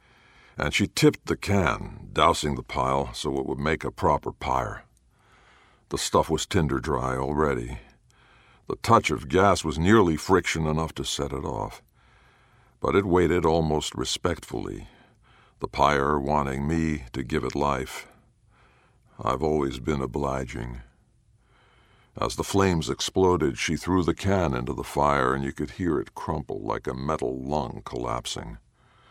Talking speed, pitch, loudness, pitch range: 150 wpm, 75 Hz, -26 LUFS, 70-85 Hz